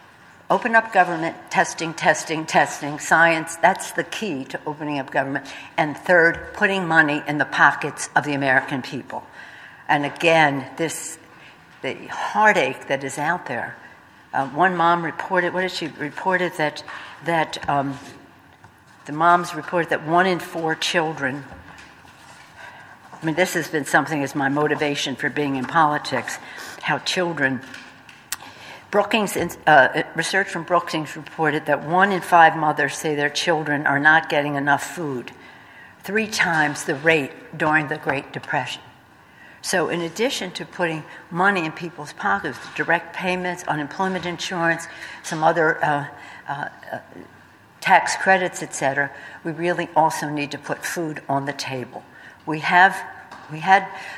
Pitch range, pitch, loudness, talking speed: 145-175 Hz, 160 Hz, -21 LUFS, 140 wpm